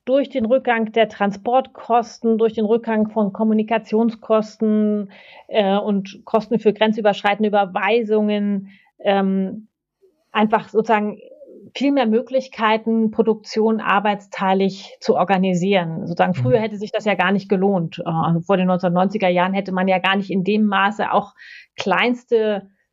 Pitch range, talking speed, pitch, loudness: 195-225 Hz, 130 wpm, 210 Hz, -19 LUFS